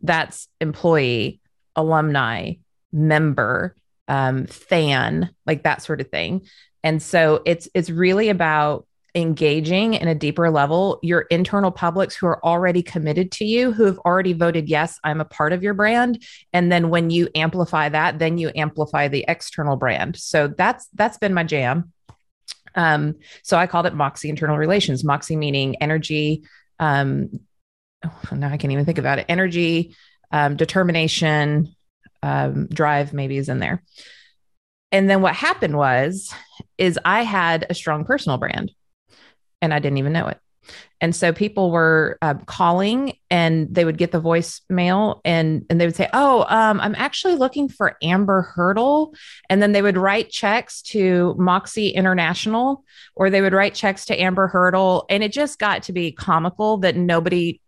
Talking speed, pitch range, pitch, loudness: 165 wpm, 155-190 Hz, 170 Hz, -19 LUFS